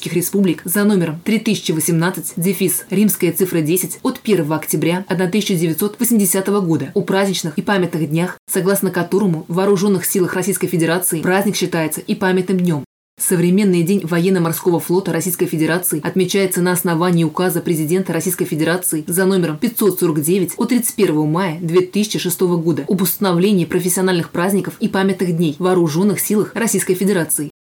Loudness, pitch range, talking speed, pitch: -17 LUFS, 170-195 Hz, 135 wpm, 180 Hz